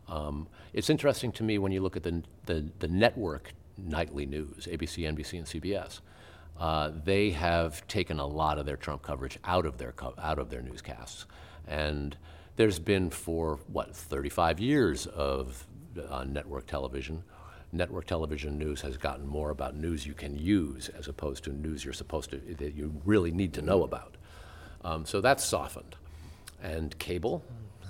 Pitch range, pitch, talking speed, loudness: 75-90 Hz, 80 Hz, 170 wpm, -32 LUFS